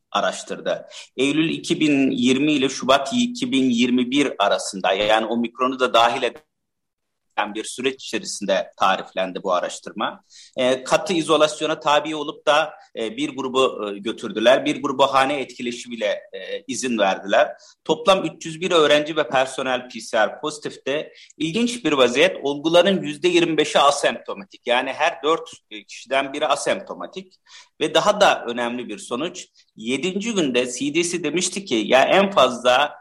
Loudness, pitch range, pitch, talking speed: -20 LUFS, 125-175 Hz, 150 Hz, 120 wpm